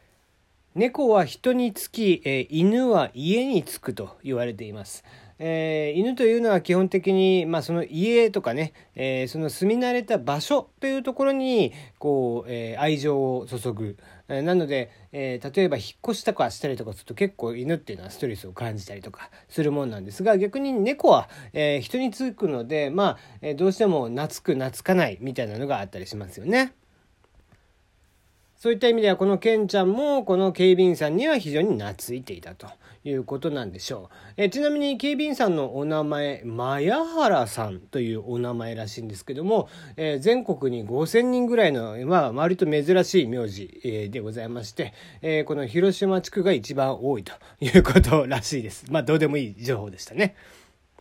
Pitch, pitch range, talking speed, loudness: 150 Hz, 120-195 Hz, 355 characters per minute, -24 LUFS